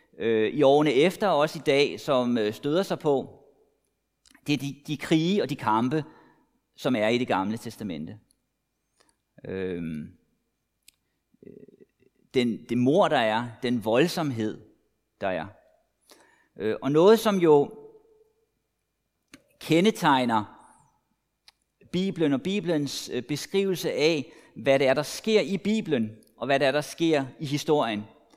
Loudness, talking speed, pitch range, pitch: -25 LUFS, 125 wpm, 125-170 Hz, 145 Hz